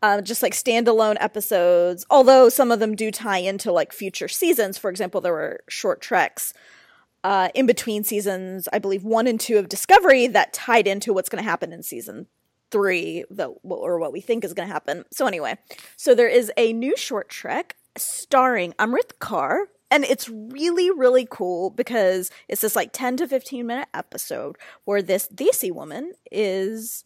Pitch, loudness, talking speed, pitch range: 225 Hz, -21 LUFS, 180 wpm, 200-265 Hz